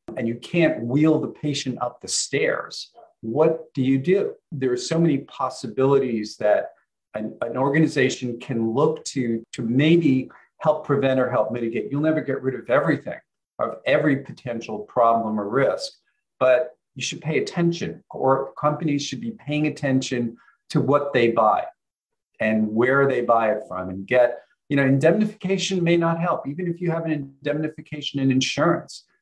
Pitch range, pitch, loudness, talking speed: 125-155 Hz, 140 Hz, -22 LUFS, 170 wpm